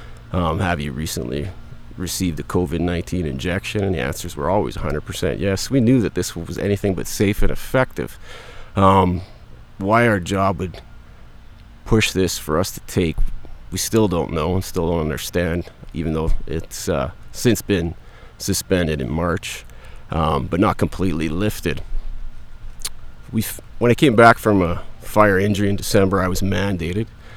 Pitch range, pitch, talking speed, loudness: 85-105 Hz, 95 Hz, 160 wpm, -20 LUFS